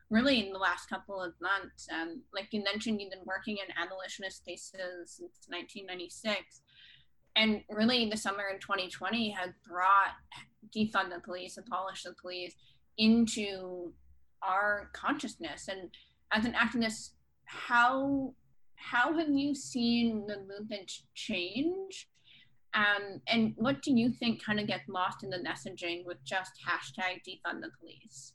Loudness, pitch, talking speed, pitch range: -33 LUFS, 200 Hz, 140 wpm, 185-230 Hz